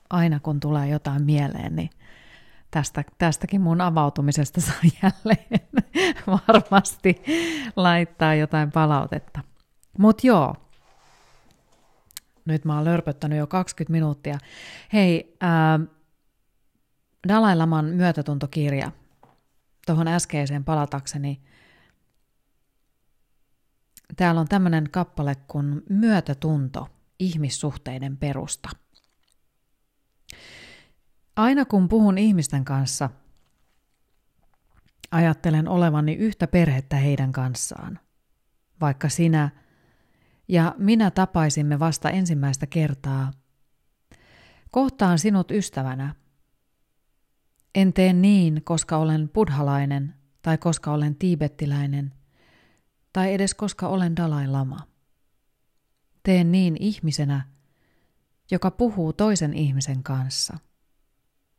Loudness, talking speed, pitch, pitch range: -22 LUFS, 85 wpm, 155 Hz, 145-185 Hz